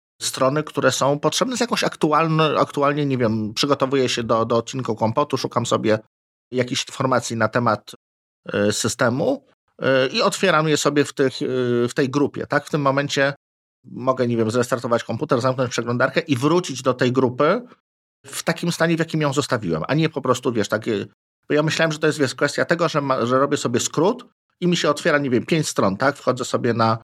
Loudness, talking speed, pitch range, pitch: -20 LUFS, 205 wpm, 120-150 Hz, 135 Hz